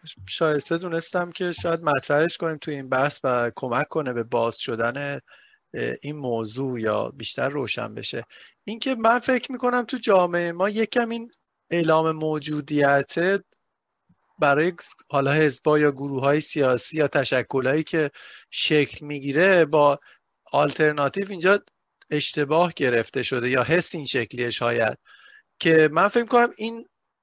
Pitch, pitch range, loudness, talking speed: 150 Hz, 140-180 Hz, -23 LUFS, 135 wpm